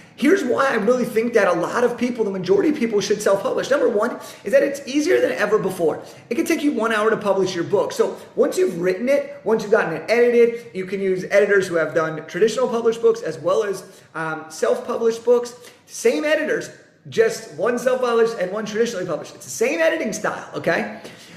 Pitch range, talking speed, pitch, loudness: 200-275 Hz, 220 wpm, 230 Hz, -20 LUFS